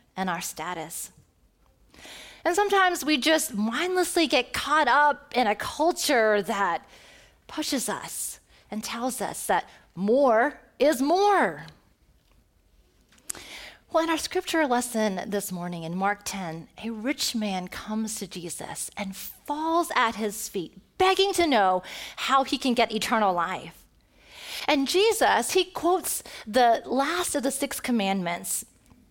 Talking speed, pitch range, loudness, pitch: 130 wpm, 205-325 Hz, -25 LUFS, 255 Hz